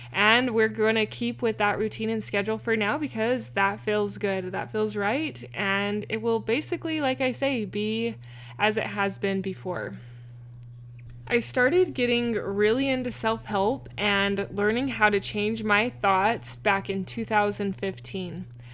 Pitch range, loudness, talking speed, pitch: 195-230 Hz, -26 LUFS, 155 wpm, 210 Hz